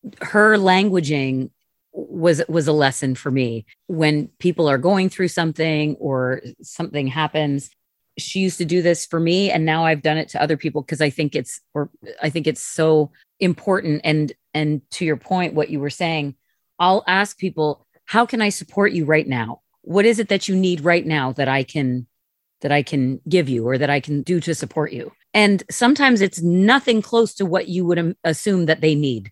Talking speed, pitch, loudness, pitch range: 200 wpm, 160 Hz, -19 LUFS, 145-185 Hz